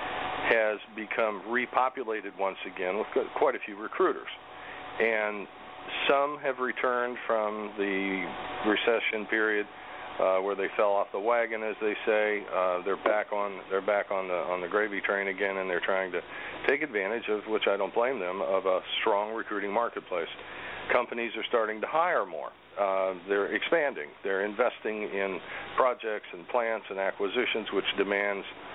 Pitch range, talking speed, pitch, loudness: 95-110 Hz, 160 wpm, 105 Hz, -29 LUFS